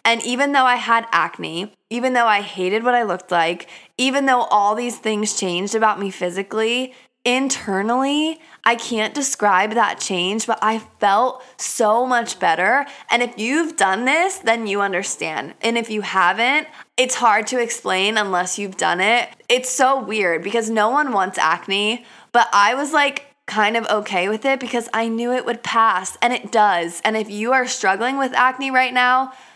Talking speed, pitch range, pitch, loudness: 185 wpm, 205-255 Hz, 230 Hz, -19 LUFS